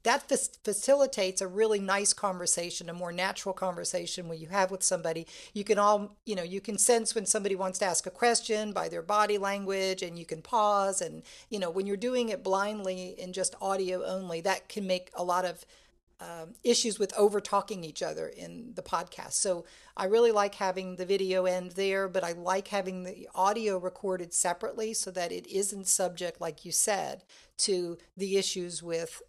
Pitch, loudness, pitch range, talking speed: 190 Hz, -30 LUFS, 180-205 Hz, 195 wpm